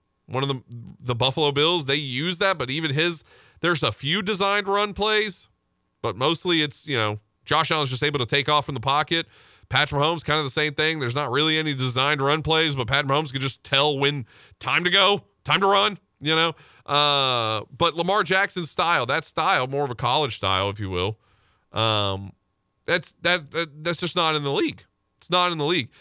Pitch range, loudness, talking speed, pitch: 125-165 Hz, -22 LUFS, 210 wpm, 145 Hz